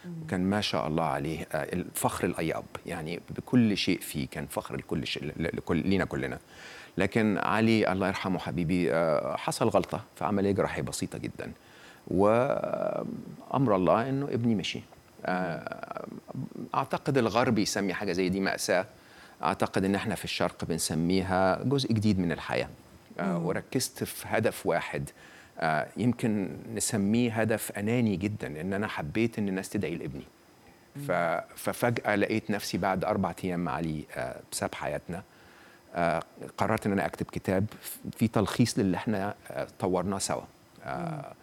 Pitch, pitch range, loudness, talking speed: 100 Hz, 90-110 Hz, -30 LUFS, 125 wpm